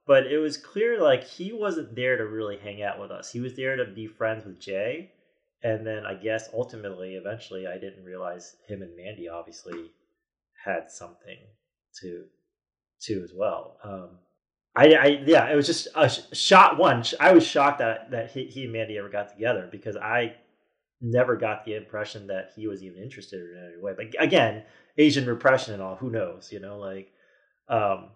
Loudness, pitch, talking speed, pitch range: -24 LUFS, 110 Hz, 190 wpm, 95-125 Hz